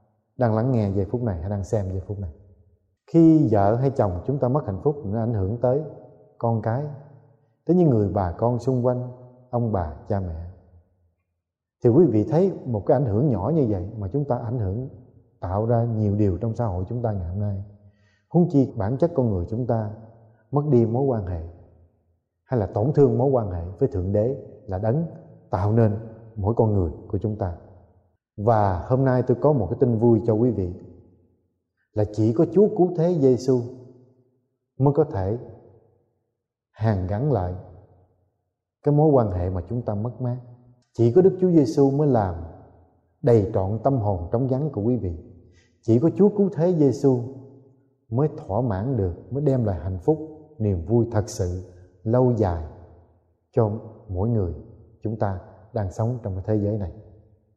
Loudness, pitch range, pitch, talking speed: -23 LUFS, 100-130 Hz, 115 Hz, 190 wpm